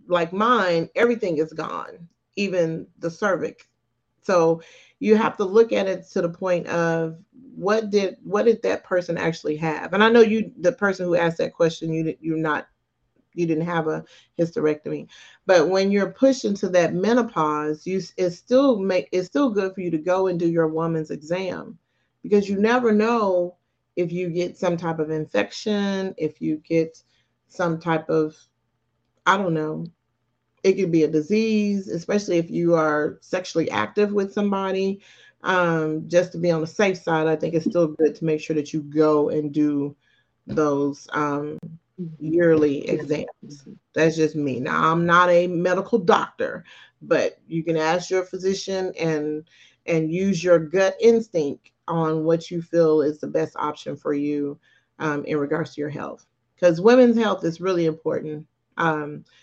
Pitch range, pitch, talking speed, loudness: 155-190 Hz, 170 Hz, 175 wpm, -22 LUFS